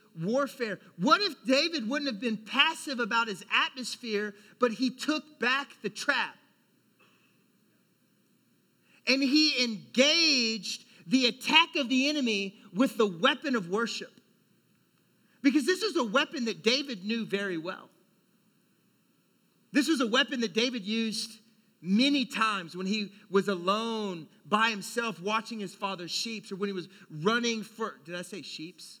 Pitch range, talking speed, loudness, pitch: 200-260 Hz, 145 wpm, -28 LUFS, 225 Hz